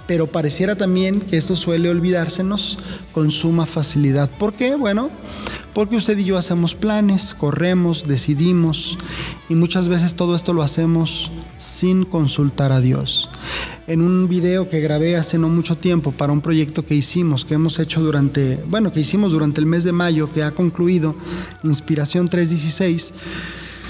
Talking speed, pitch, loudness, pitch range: 160 wpm, 170 Hz, -18 LUFS, 155-180 Hz